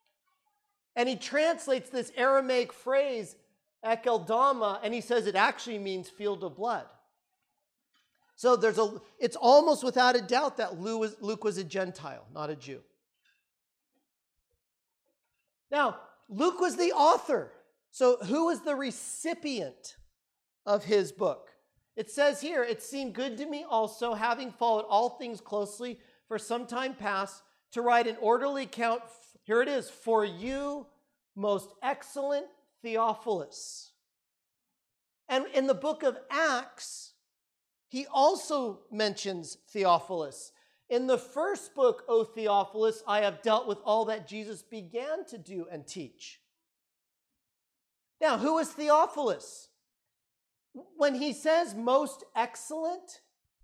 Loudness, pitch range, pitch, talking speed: -30 LUFS, 220-290 Hz, 245 Hz, 125 wpm